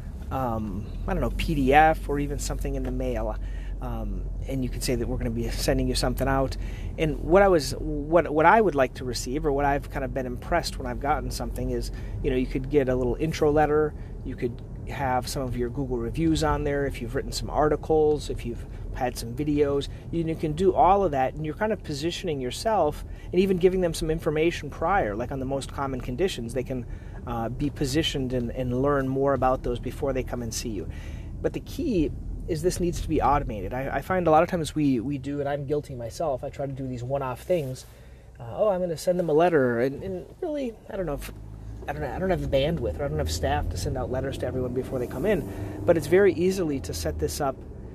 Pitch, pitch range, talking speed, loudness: 130 Hz, 120-150 Hz, 245 wpm, -26 LUFS